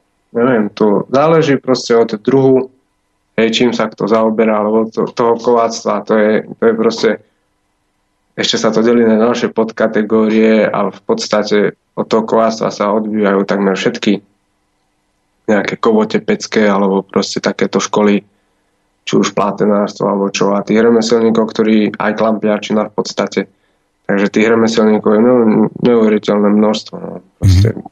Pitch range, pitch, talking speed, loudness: 100-115 Hz, 110 Hz, 140 wpm, -13 LUFS